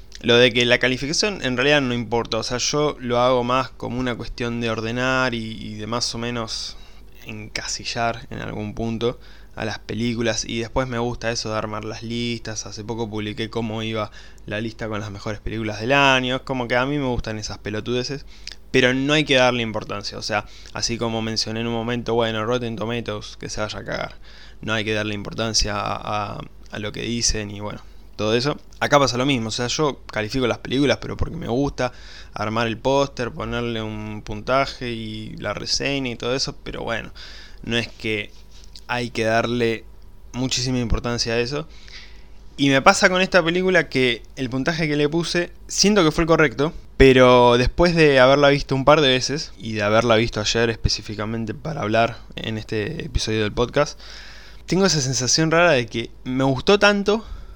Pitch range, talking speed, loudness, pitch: 110-130 Hz, 195 wpm, -21 LUFS, 115 Hz